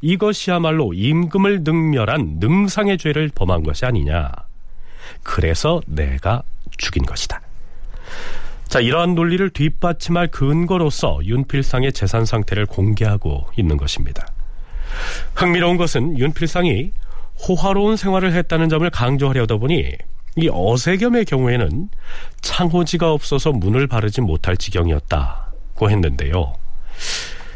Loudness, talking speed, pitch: -18 LUFS, 285 characters per minute, 135 Hz